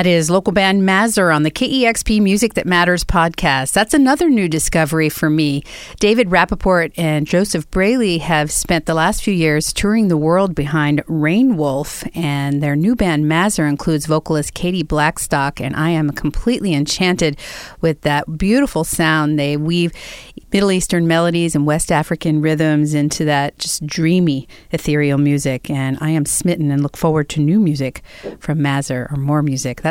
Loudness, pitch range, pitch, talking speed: -16 LUFS, 150-180 Hz, 160 Hz, 165 wpm